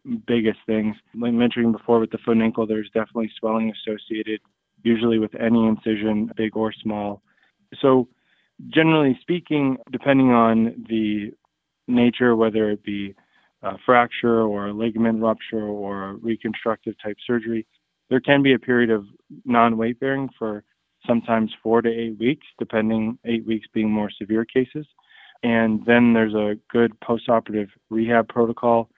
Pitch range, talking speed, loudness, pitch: 110-120 Hz, 150 wpm, -21 LUFS, 115 Hz